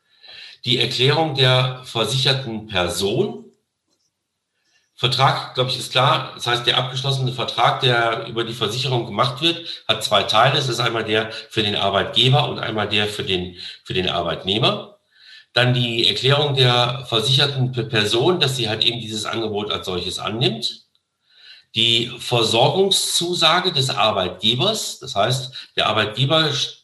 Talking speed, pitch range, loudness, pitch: 140 wpm, 115-135 Hz, -19 LUFS, 125 Hz